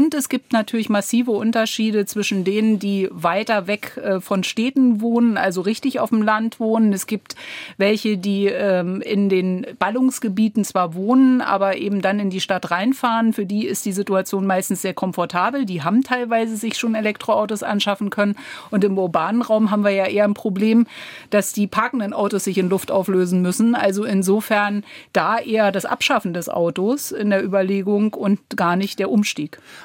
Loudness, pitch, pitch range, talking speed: -19 LUFS, 205 Hz, 195-225 Hz, 175 wpm